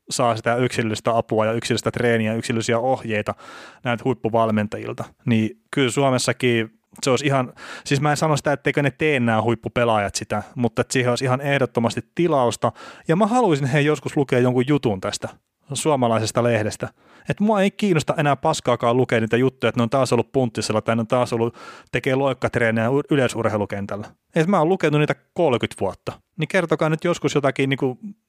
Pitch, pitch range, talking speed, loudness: 125 Hz, 115-145 Hz, 175 wpm, -21 LUFS